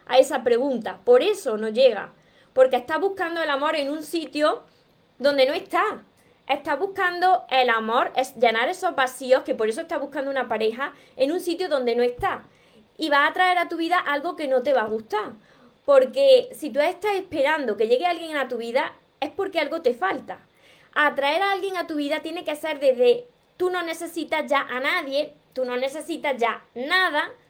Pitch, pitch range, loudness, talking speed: 295 Hz, 260-350 Hz, -23 LUFS, 200 wpm